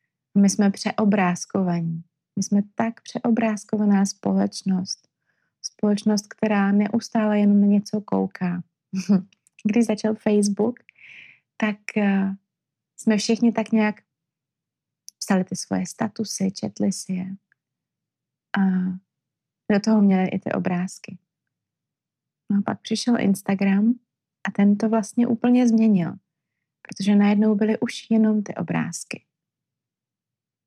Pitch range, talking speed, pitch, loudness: 180-215 Hz, 110 wpm, 200 Hz, -22 LUFS